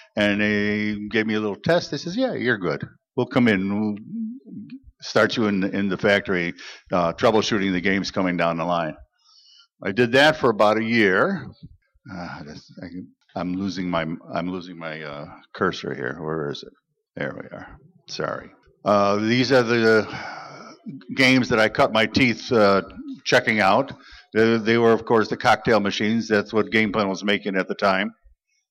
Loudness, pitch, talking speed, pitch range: -21 LUFS, 105 Hz, 175 wpm, 95-125 Hz